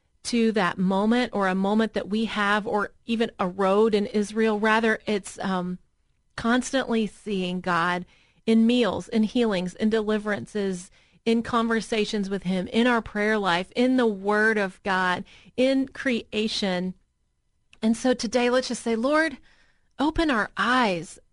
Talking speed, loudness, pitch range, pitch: 145 wpm, -24 LUFS, 190-230 Hz, 215 Hz